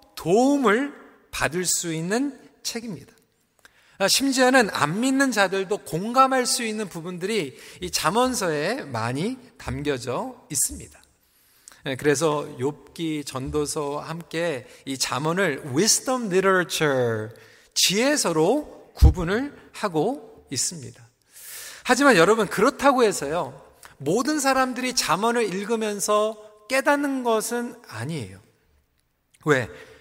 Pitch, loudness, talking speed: 195 Hz, -23 LUFS, 250 characters per minute